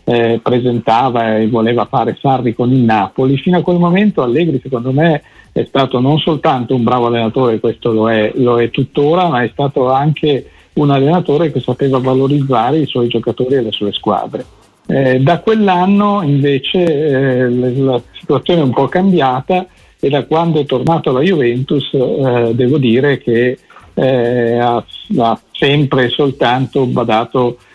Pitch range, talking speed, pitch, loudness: 120-145 Hz, 160 wpm, 130 Hz, -13 LUFS